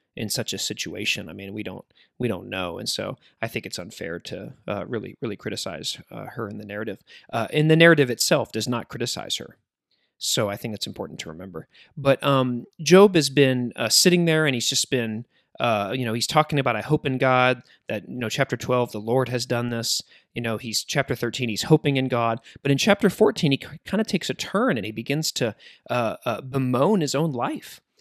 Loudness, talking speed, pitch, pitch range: -23 LUFS, 225 wpm, 125 Hz, 115-145 Hz